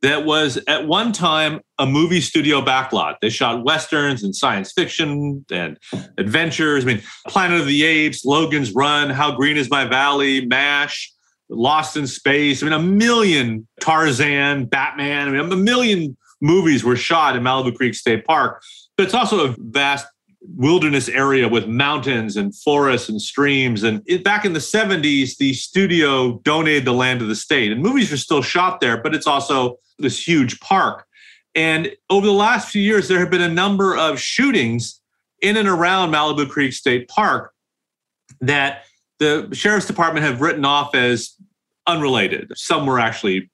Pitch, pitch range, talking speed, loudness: 145 Hz, 135-175 Hz, 170 wpm, -17 LUFS